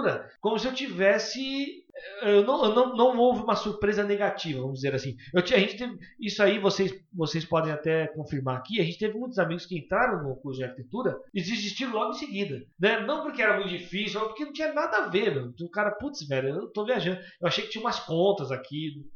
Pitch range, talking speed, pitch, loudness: 160-235 Hz, 230 wpm, 200 Hz, -28 LUFS